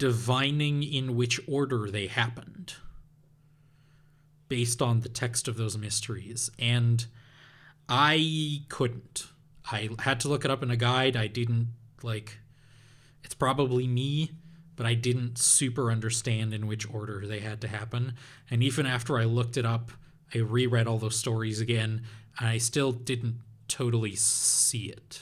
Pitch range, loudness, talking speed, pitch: 115-140 Hz, -28 LUFS, 150 wpm, 125 Hz